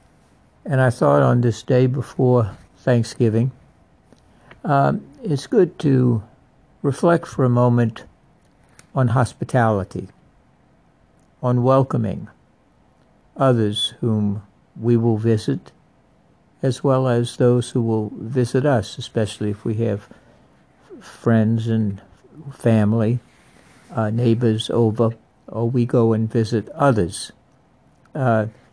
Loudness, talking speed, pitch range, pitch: -20 LUFS, 100 wpm, 110-130 Hz, 120 Hz